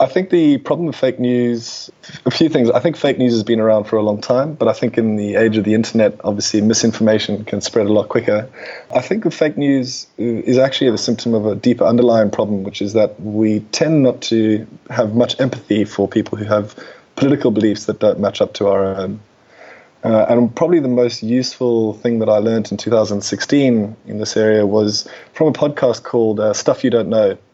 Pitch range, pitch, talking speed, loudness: 105-125 Hz, 115 Hz, 215 wpm, -16 LUFS